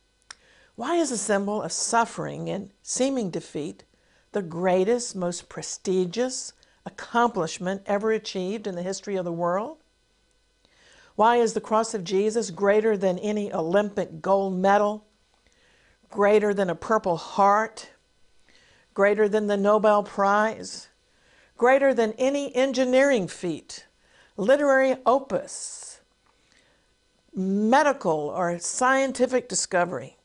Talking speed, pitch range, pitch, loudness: 110 wpm, 190-235 Hz, 210 Hz, -24 LUFS